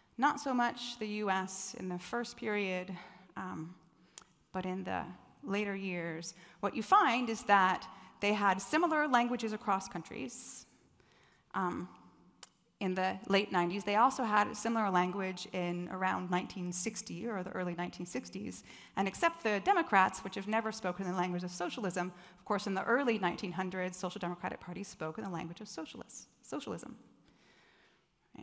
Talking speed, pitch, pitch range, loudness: 155 wpm, 190 Hz, 180-215 Hz, -35 LUFS